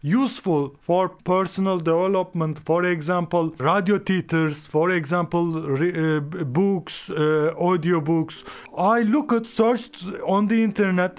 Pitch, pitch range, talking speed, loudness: 175 Hz, 160-195 Hz, 125 wpm, -22 LUFS